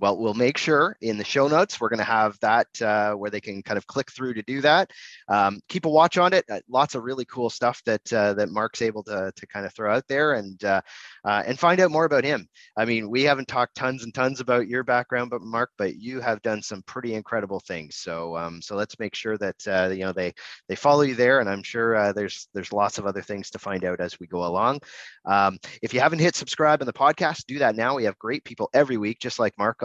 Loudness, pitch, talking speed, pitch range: -24 LUFS, 110 Hz, 265 wpm, 100-130 Hz